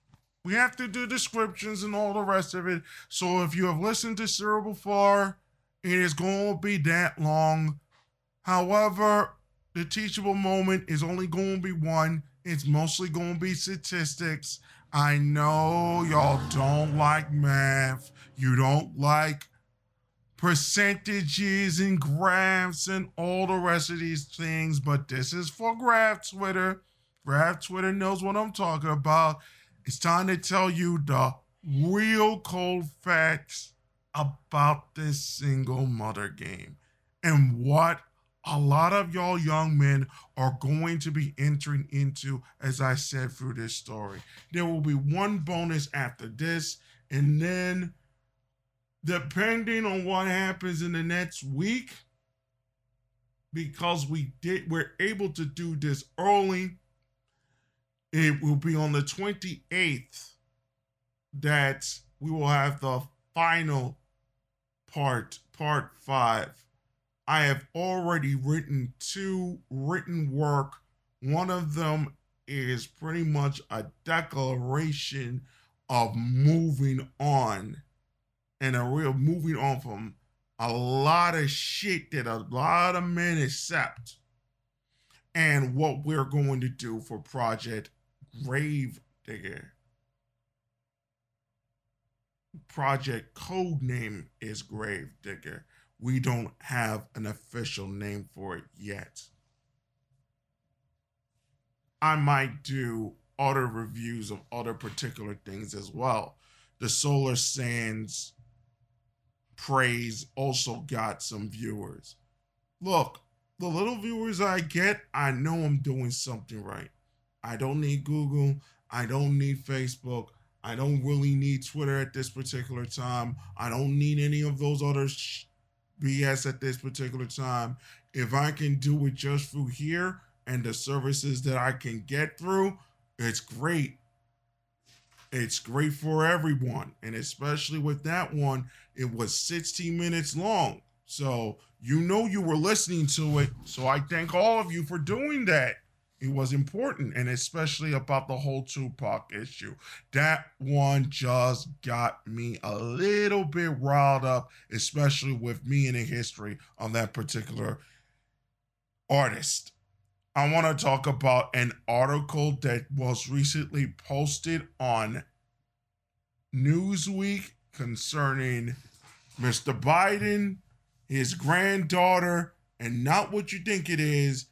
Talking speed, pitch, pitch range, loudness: 130 wpm, 140 Hz, 125-165 Hz, -28 LUFS